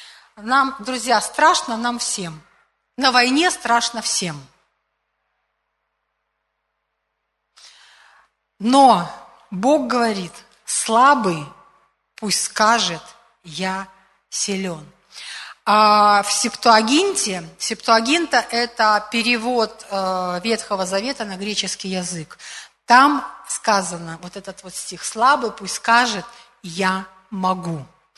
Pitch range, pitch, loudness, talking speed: 190-240 Hz, 215 Hz, -18 LUFS, 85 wpm